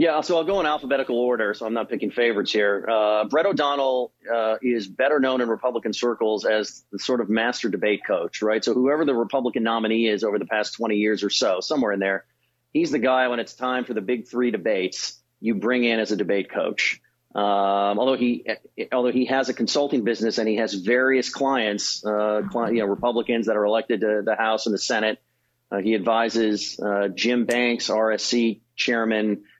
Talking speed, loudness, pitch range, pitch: 205 wpm, -23 LUFS, 105-125 Hz, 115 Hz